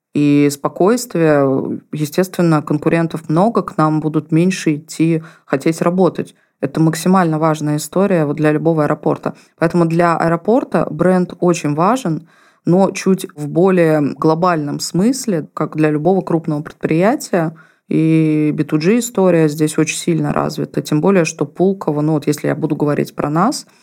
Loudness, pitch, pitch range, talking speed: -16 LUFS, 160 Hz, 155-180 Hz, 140 wpm